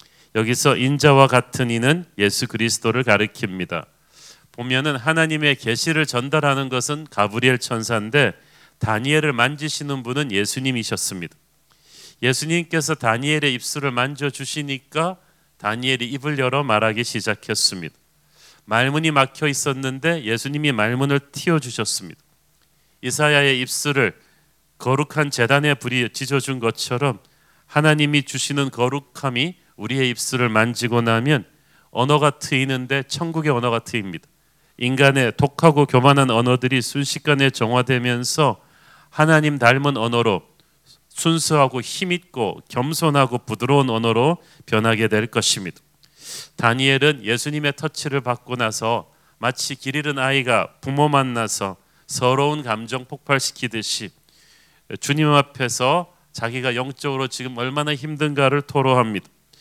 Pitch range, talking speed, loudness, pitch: 120-150 Hz, 305 characters per minute, -20 LUFS, 135 Hz